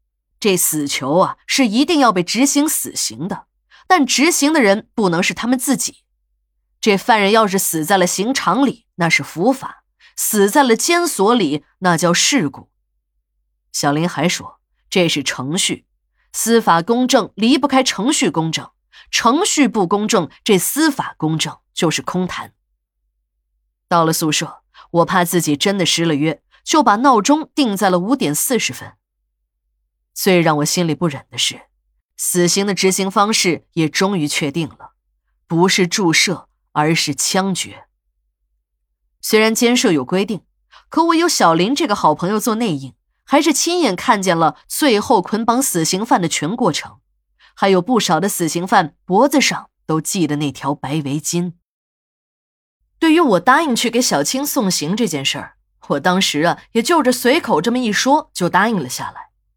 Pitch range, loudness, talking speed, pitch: 150-235 Hz, -16 LUFS, 230 characters per minute, 180 Hz